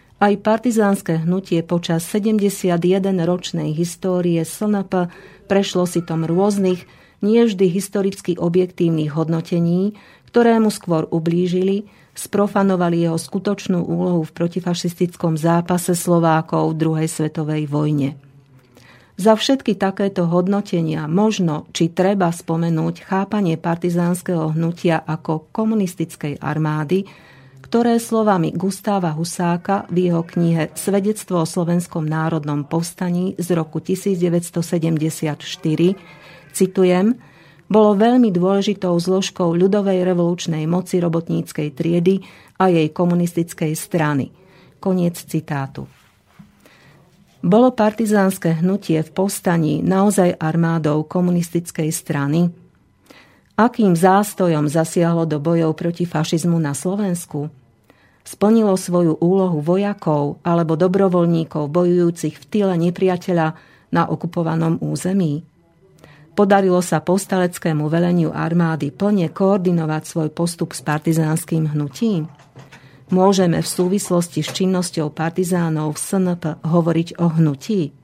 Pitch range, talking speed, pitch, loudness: 160-190 Hz, 100 wpm, 175 Hz, -19 LUFS